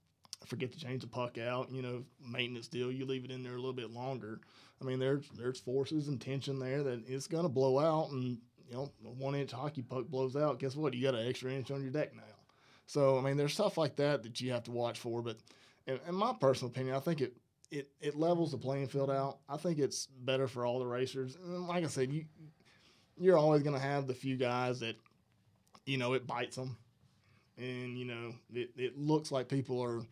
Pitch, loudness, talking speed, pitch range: 130 Hz, -37 LUFS, 240 wpm, 125-140 Hz